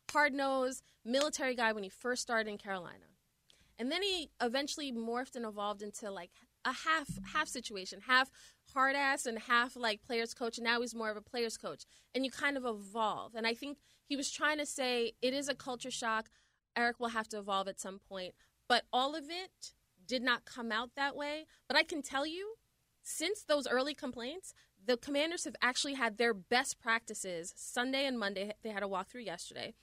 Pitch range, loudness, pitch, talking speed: 225-280 Hz, -36 LUFS, 245 Hz, 200 wpm